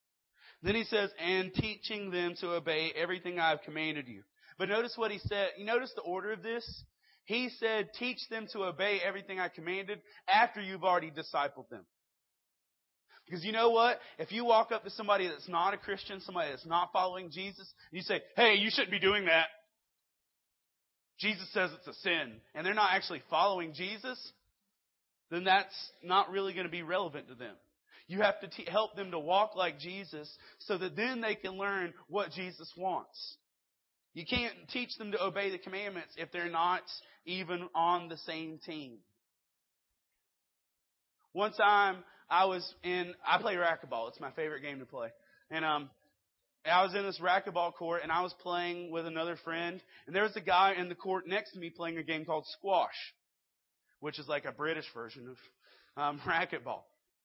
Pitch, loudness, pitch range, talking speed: 185 Hz, -34 LUFS, 165-205 Hz, 185 wpm